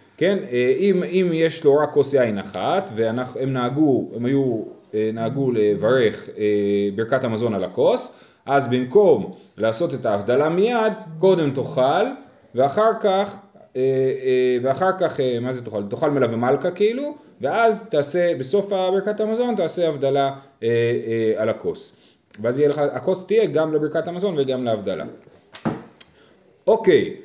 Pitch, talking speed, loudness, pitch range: 140 Hz, 120 wpm, -21 LUFS, 125-185 Hz